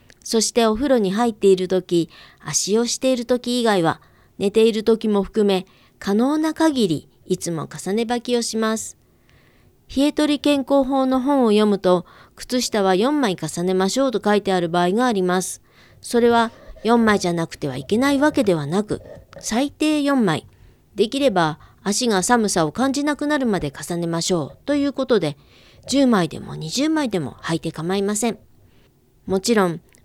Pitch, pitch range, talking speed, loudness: 215 Hz, 180-255 Hz, 305 characters per minute, -20 LUFS